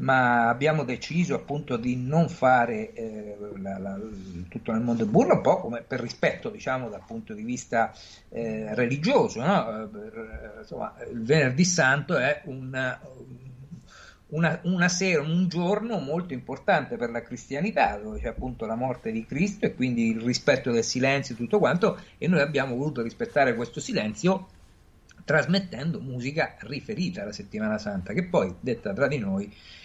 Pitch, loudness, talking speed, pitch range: 130 Hz, -26 LUFS, 155 wpm, 115-180 Hz